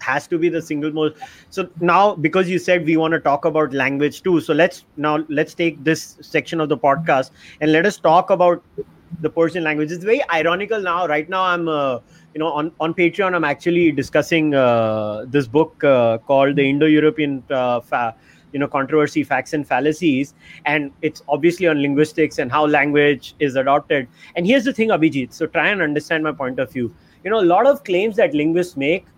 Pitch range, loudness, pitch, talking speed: 145-170 Hz, -18 LUFS, 155 Hz, 205 wpm